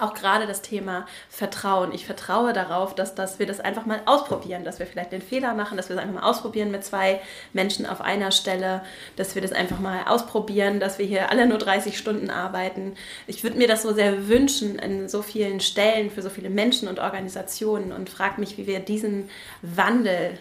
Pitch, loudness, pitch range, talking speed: 195 Hz, -24 LUFS, 190-215 Hz, 210 wpm